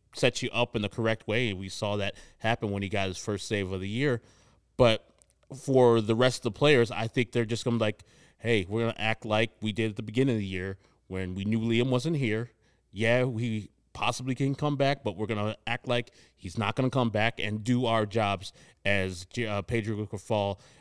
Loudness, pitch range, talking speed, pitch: -29 LUFS, 105-120 Hz, 235 wpm, 115 Hz